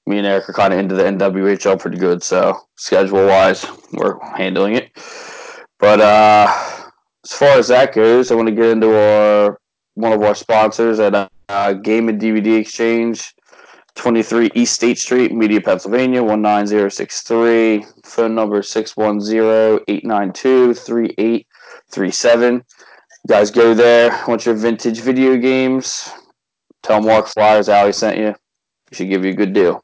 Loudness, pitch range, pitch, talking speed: -14 LUFS, 105-115 Hz, 110 Hz, 170 wpm